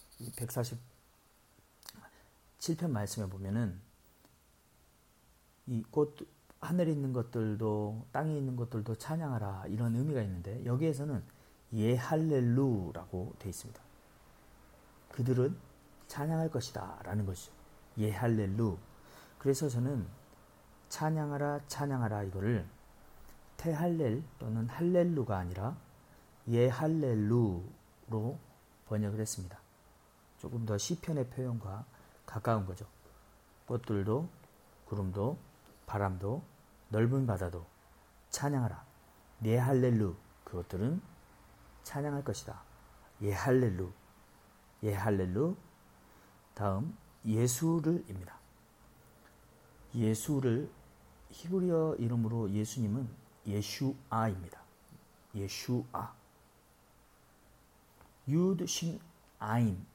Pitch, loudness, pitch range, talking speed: 115 Hz, -35 LUFS, 100-140 Hz, 200 characters per minute